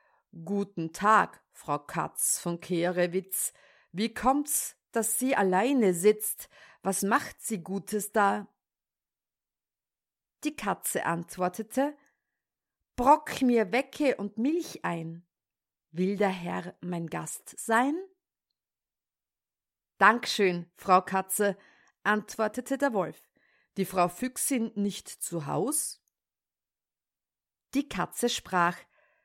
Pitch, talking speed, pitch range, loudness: 205 Hz, 100 wpm, 185-250 Hz, -29 LUFS